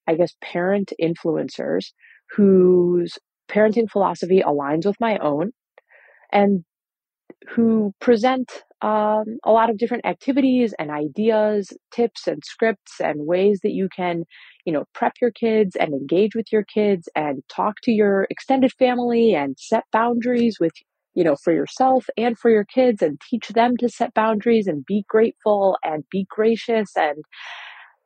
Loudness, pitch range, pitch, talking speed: -20 LUFS, 185-230 Hz, 215 Hz, 150 wpm